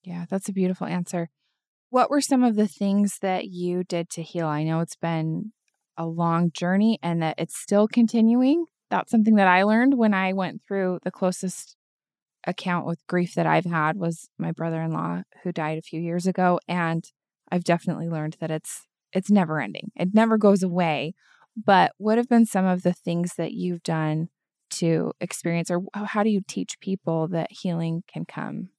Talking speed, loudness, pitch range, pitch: 190 wpm, -24 LUFS, 165-205 Hz, 180 Hz